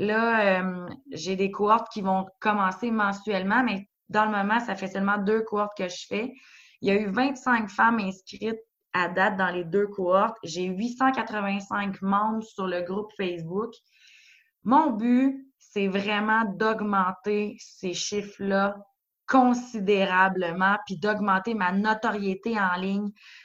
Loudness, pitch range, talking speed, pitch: -26 LUFS, 190-225 Hz, 140 wpm, 205 Hz